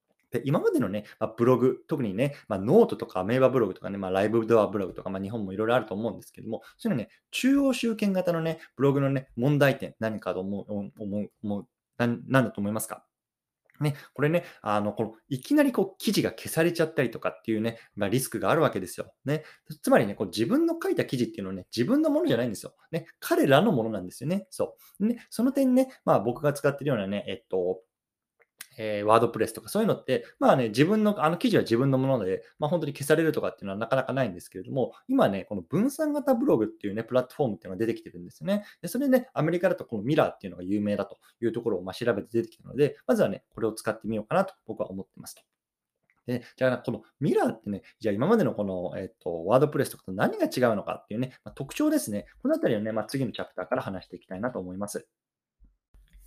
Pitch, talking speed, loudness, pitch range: 125 Hz, 485 characters per minute, -27 LUFS, 105-165 Hz